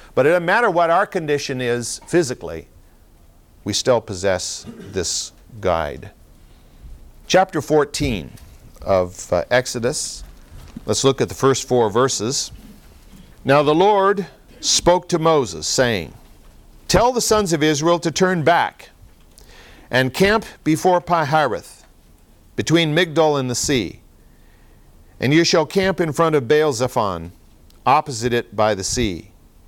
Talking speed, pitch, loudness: 125 wpm, 130 Hz, -18 LUFS